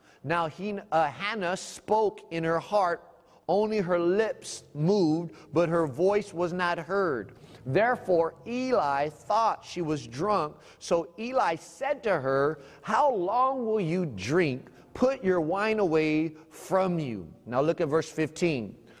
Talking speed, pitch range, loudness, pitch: 140 wpm, 155-200 Hz, -28 LUFS, 170 Hz